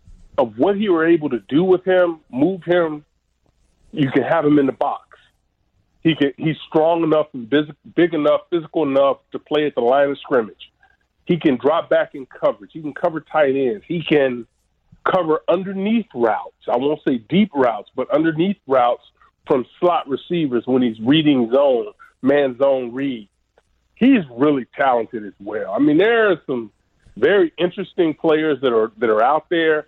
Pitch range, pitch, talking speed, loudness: 135-180 Hz, 155 Hz, 175 wpm, -18 LUFS